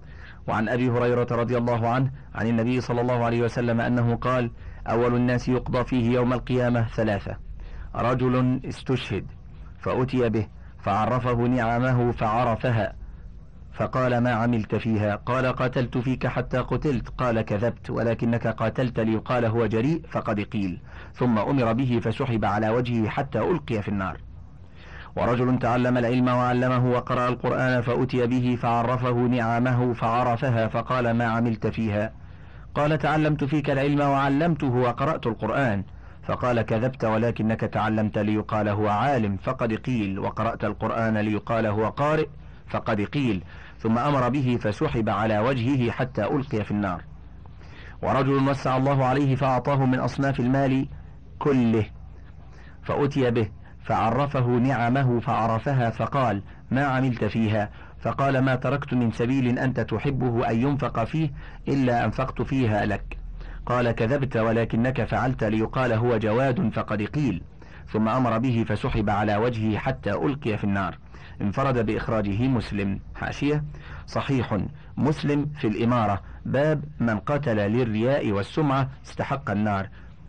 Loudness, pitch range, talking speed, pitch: -25 LUFS, 110-130 Hz, 125 wpm, 120 Hz